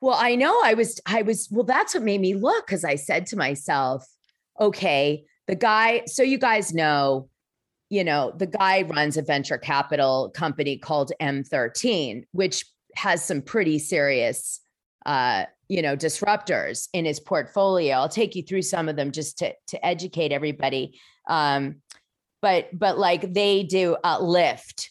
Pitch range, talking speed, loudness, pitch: 145-205 Hz, 165 wpm, -23 LUFS, 175 Hz